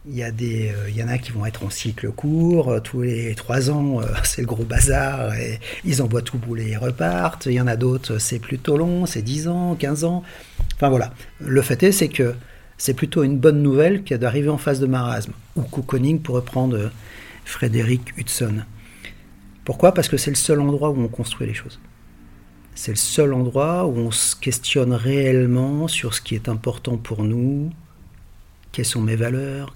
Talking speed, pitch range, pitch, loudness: 205 wpm, 115-140 Hz, 125 Hz, -21 LUFS